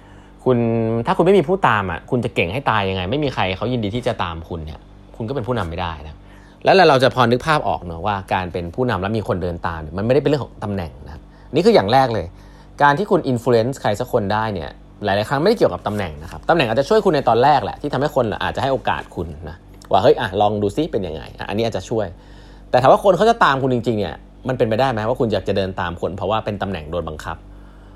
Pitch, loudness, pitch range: 105 Hz, -19 LUFS, 95-130 Hz